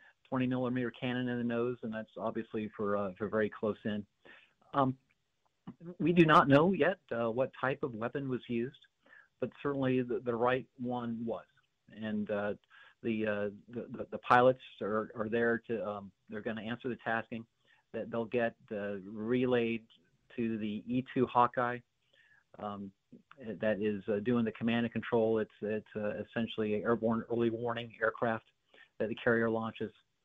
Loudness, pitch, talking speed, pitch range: -34 LUFS, 115 Hz, 165 wpm, 110-125 Hz